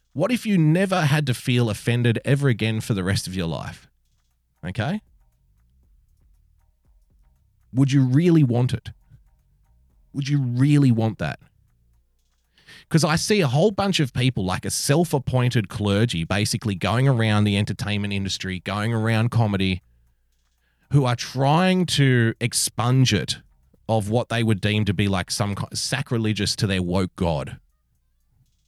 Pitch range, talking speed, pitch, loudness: 90-130 Hz, 140 wpm, 110 Hz, -22 LUFS